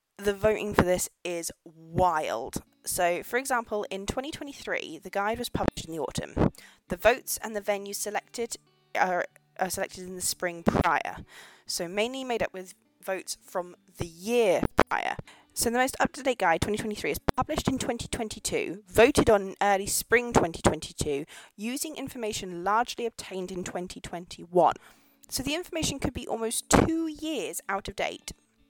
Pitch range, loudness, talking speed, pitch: 185-240 Hz, -28 LUFS, 155 wpm, 205 Hz